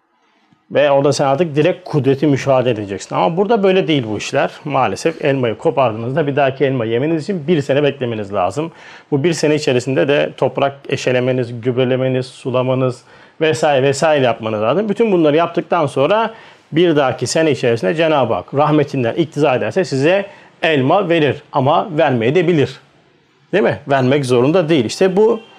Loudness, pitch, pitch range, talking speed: -15 LUFS, 145 Hz, 130-165 Hz, 155 wpm